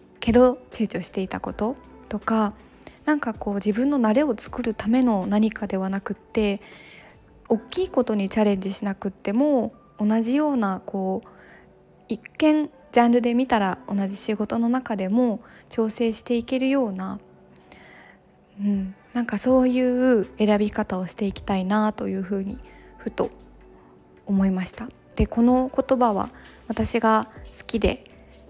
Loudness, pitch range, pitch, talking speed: -23 LUFS, 200-245 Hz, 215 Hz, 285 characters per minute